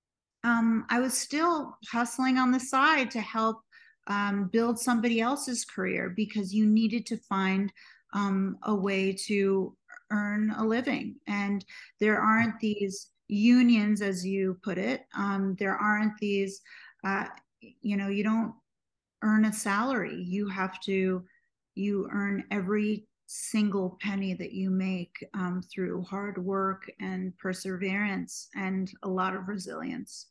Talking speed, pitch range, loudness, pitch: 140 wpm, 195-230 Hz, -29 LUFS, 205 Hz